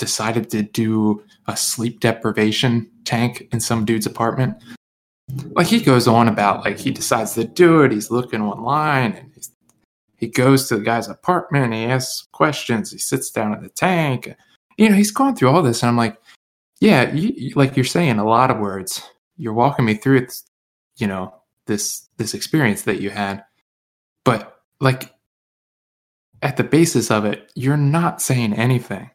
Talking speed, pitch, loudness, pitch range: 180 wpm, 120 Hz, -18 LUFS, 110-135 Hz